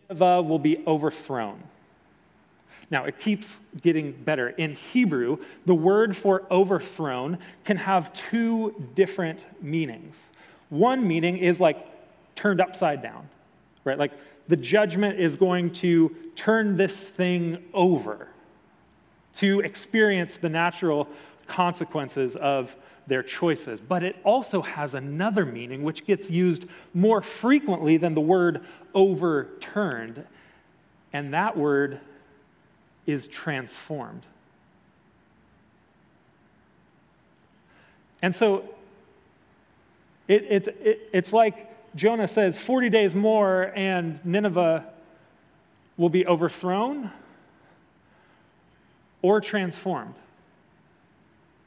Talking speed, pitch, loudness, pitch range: 100 wpm, 180 Hz, -24 LUFS, 160-200 Hz